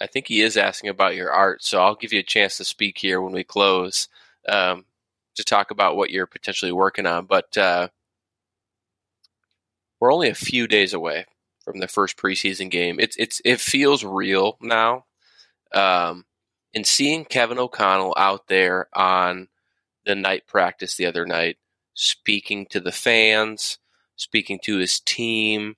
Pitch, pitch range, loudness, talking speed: 100 Hz, 90-110 Hz, -20 LUFS, 165 wpm